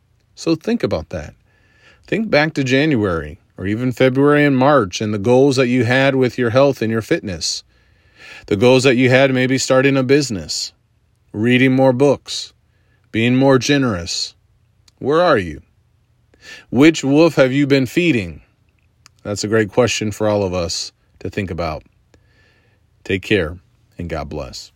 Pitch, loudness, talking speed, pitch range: 115 Hz, -16 LUFS, 160 wpm, 105-135 Hz